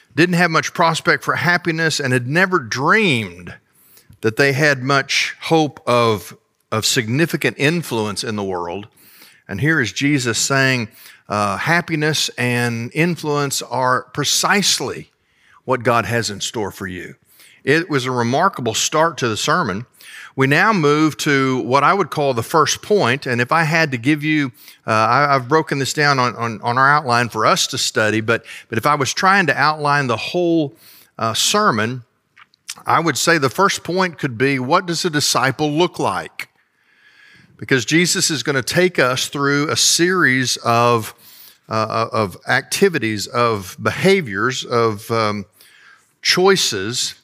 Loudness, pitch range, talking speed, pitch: -17 LUFS, 120-165 Hz, 160 wpm, 140 Hz